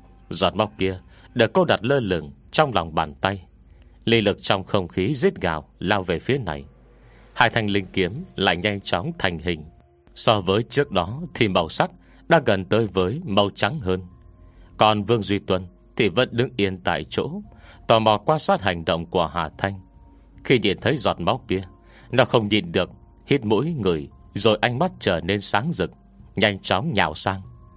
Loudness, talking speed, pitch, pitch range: -22 LUFS, 190 wpm, 95 Hz, 90-110 Hz